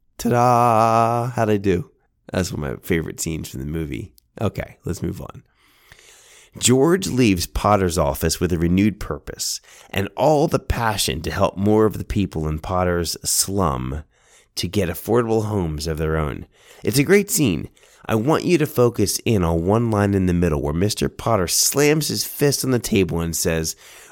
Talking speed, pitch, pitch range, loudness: 180 wpm, 95 Hz, 80-115 Hz, -20 LUFS